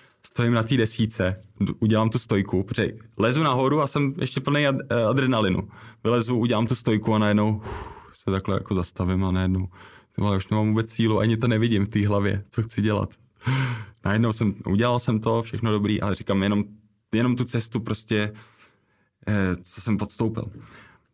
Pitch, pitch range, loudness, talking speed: 110 Hz, 100-115 Hz, -24 LUFS, 165 wpm